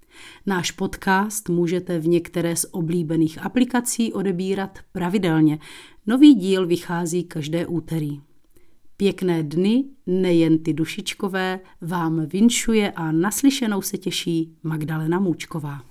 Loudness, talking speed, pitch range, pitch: -22 LUFS, 105 wpm, 165-195 Hz, 175 Hz